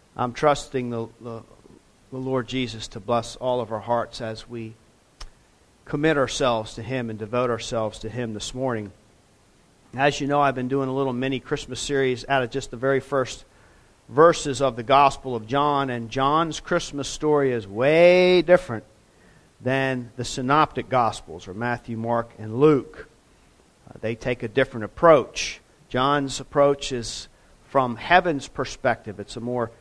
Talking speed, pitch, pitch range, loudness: 160 wpm, 125 Hz, 115-140 Hz, -23 LUFS